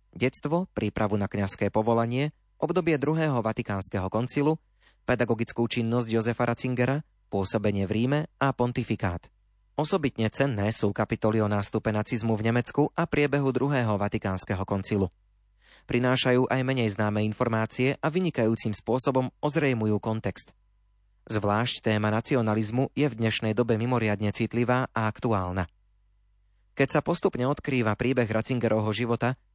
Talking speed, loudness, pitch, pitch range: 120 wpm, -27 LUFS, 115 Hz, 105-130 Hz